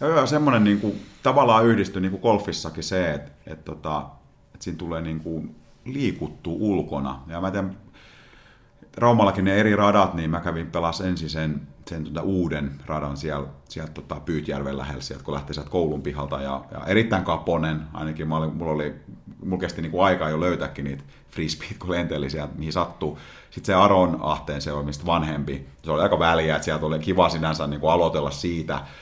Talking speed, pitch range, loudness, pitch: 175 wpm, 75-95 Hz, -24 LUFS, 80 Hz